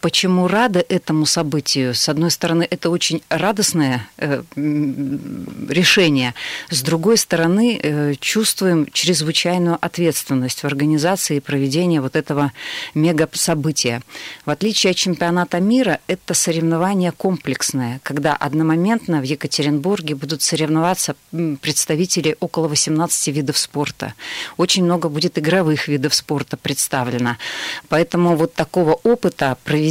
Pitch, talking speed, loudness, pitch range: 160 Hz, 110 wpm, -18 LUFS, 150-175 Hz